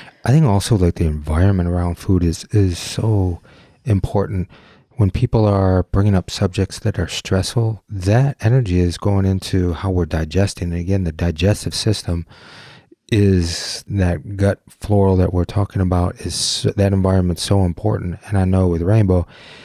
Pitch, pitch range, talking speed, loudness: 95 Hz, 90-105 Hz, 160 wpm, -18 LUFS